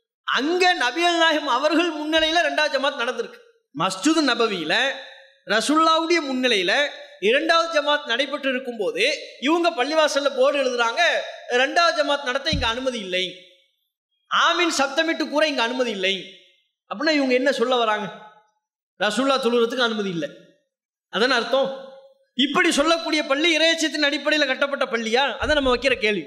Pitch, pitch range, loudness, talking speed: 280 Hz, 245-320 Hz, -20 LUFS, 125 wpm